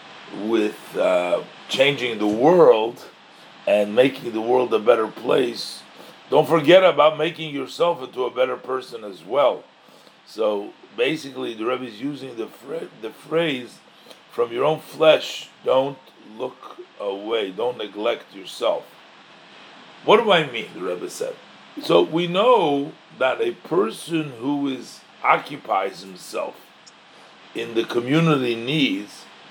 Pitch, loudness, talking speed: 155 Hz, -21 LUFS, 130 wpm